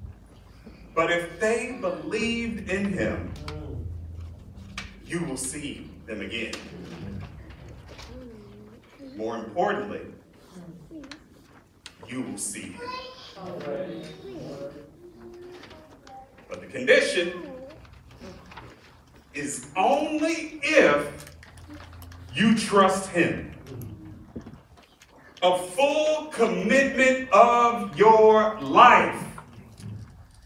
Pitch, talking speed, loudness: 170 Hz, 65 wpm, -23 LUFS